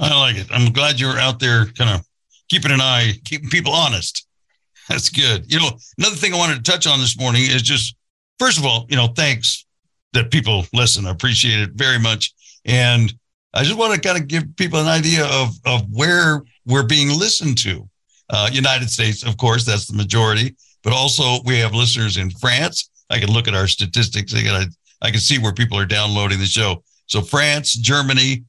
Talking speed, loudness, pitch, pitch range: 200 wpm, -16 LUFS, 125 Hz, 110-145 Hz